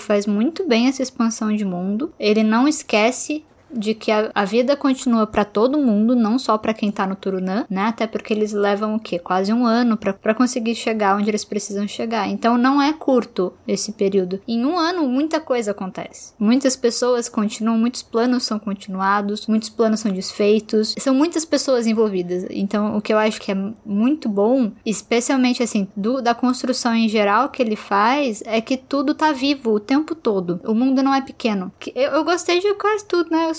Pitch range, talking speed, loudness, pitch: 210-260 Hz, 195 wpm, -19 LUFS, 225 Hz